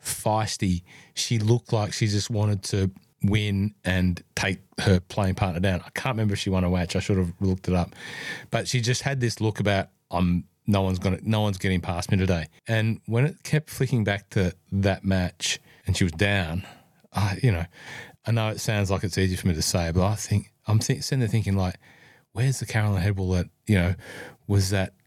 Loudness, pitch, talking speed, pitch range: -26 LUFS, 100 Hz, 220 wpm, 95-110 Hz